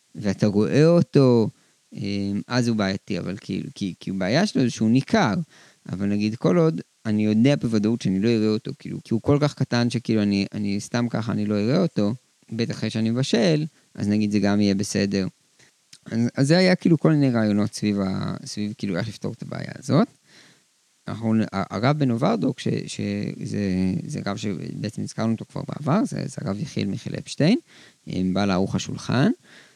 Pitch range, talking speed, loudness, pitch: 100-125 Hz, 175 wpm, -23 LUFS, 110 Hz